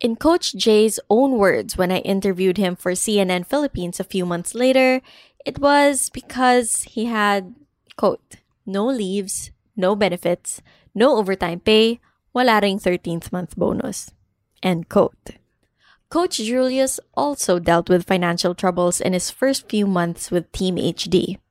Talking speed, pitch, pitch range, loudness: 140 wpm, 195 Hz, 180-245 Hz, -19 LUFS